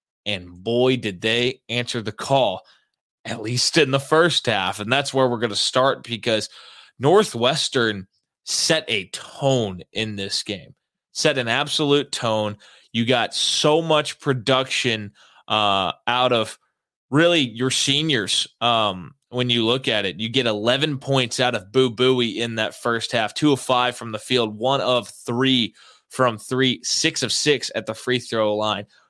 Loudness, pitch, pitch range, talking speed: -21 LUFS, 125 Hz, 110-130 Hz, 165 wpm